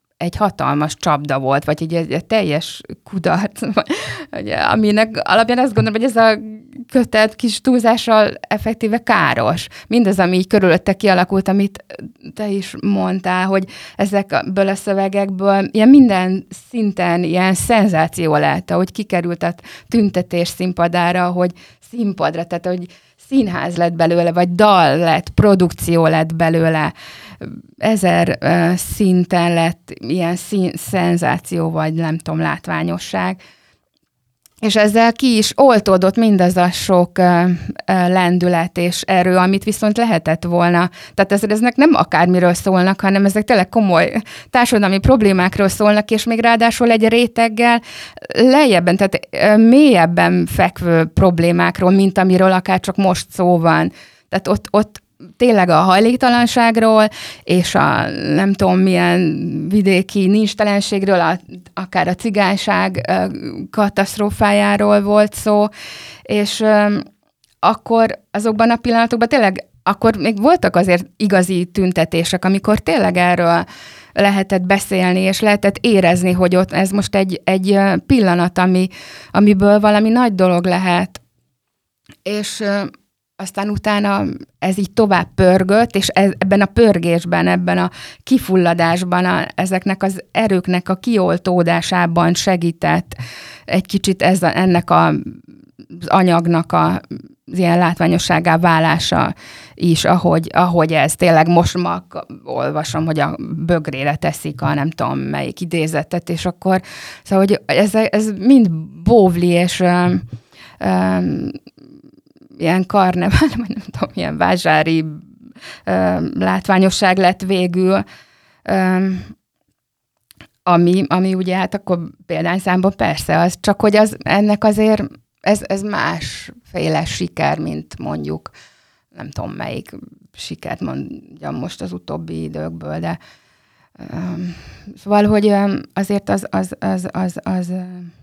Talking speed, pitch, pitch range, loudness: 120 wpm, 185 Hz, 170-210 Hz, -15 LUFS